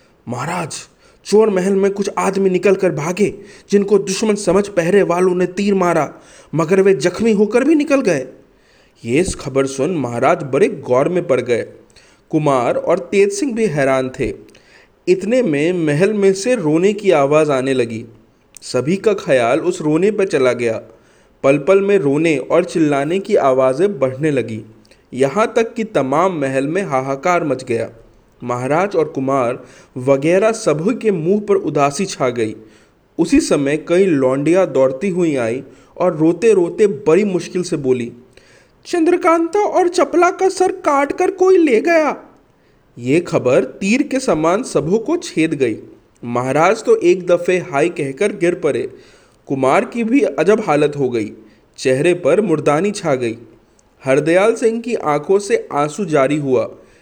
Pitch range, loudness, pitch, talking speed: 135-210 Hz, -16 LUFS, 180 Hz, 160 wpm